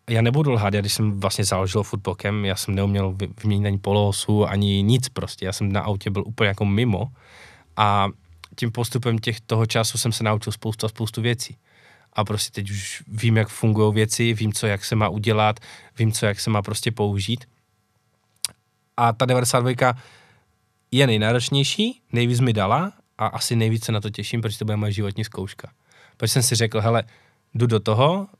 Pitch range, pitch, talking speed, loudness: 105-120 Hz, 110 Hz, 185 wpm, -22 LUFS